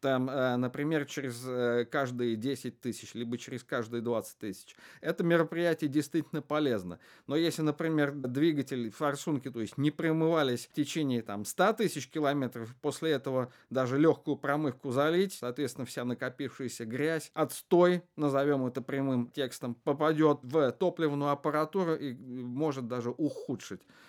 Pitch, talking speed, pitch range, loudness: 140 Hz, 130 wpm, 125-155 Hz, -32 LUFS